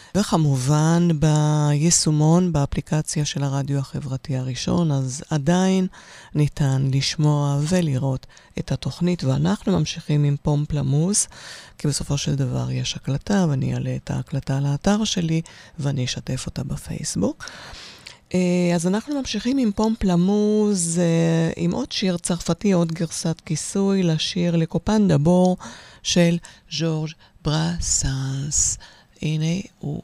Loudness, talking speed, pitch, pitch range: -22 LUFS, 110 wpm, 160 Hz, 145-180 Hz